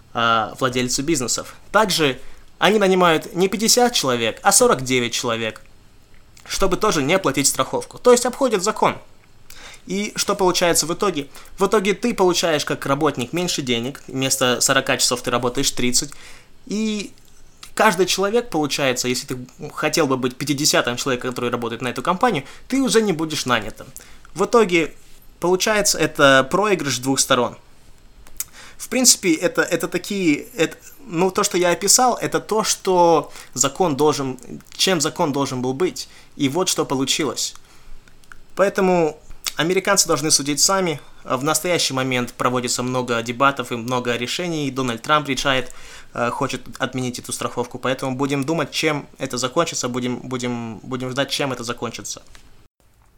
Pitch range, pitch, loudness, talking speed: 125-180 Hz, 145 Hz, -19 LUFS, 140 wpm